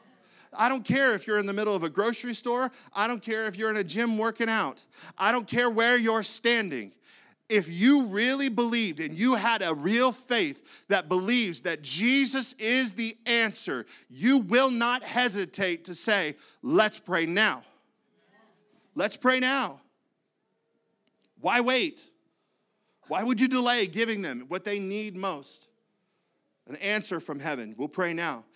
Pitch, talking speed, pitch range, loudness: 225 Hz, 160 wpm, 195-245 Hz, -26 LUFS